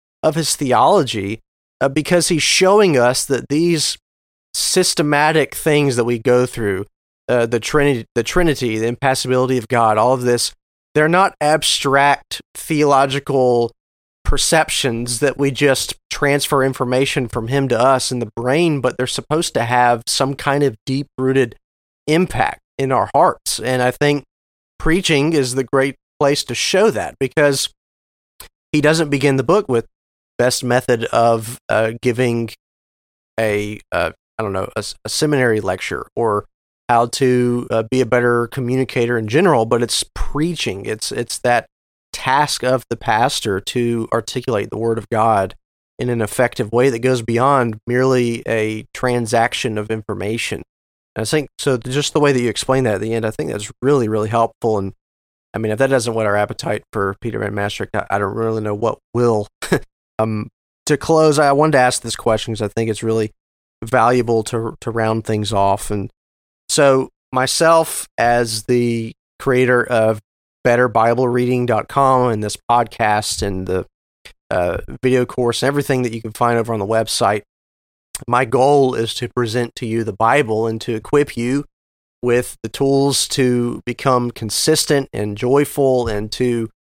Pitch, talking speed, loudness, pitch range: 120 Hz, 165 wpm, -17 LUFS, 110-135 Hz